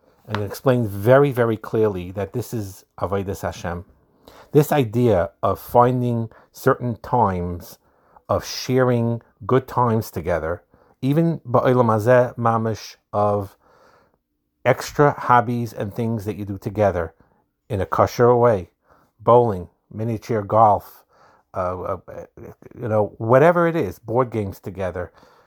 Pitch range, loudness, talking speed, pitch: 100-125 Hz, -20 LUFS, 115 wpm, 115 Hz